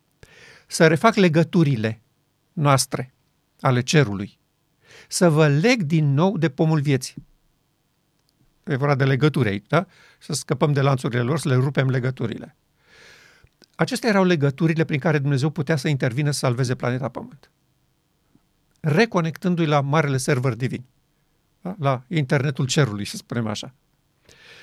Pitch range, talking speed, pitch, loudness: 135-160 Hz, 130 wpm, 150 Hz, -21 LUFS